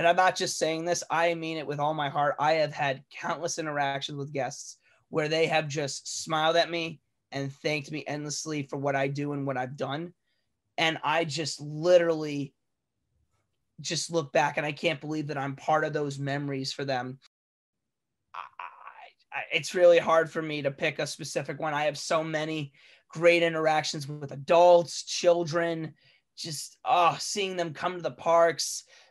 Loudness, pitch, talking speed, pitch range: -28 LUFS, 155 Hz, 180 wpm, 140-165 Hz